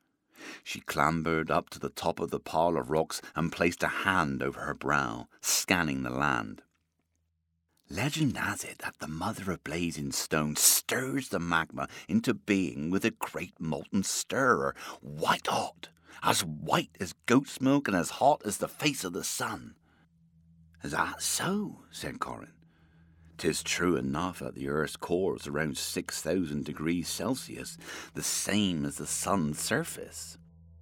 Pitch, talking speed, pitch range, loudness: 80 Hz, 150 wpm, 75-85 Hz, -30 LUFS